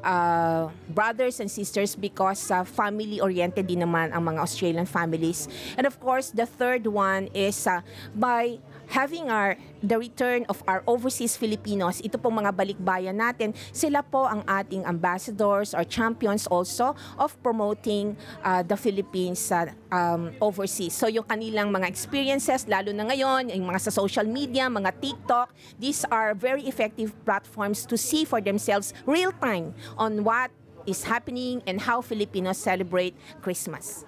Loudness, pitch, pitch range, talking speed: -26 LUFS, 210 Hz, 185-240 Hz, 150 wpm